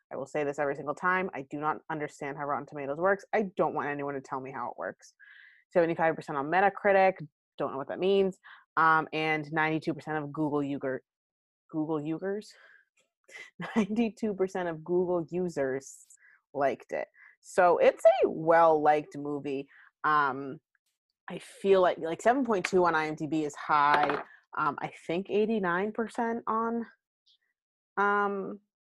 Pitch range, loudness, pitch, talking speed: 150-200 Hz, -29 LUFS, 165 Hz, 155 wpm